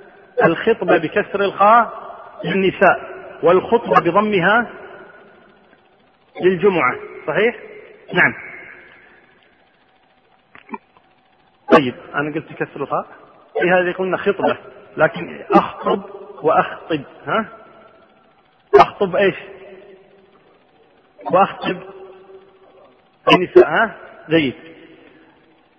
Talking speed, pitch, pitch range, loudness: 65 wpm, 195 Hz, 185-215 Hz, -17 LUFS